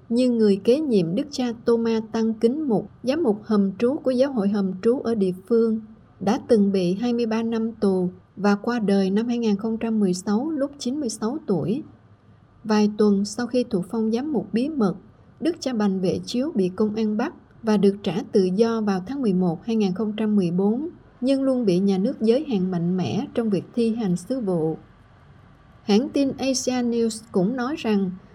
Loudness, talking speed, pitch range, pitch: -23 LUFS, 180 wpm, 200-240 Hz, 220 Hz